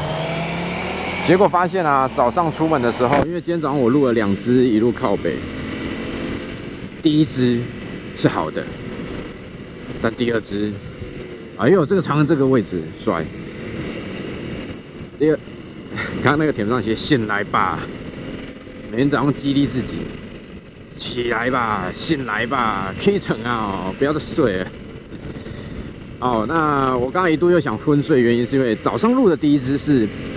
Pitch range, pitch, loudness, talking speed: 120-160 Hz, 135 Hz, -19 LUFS, 215 characters per minute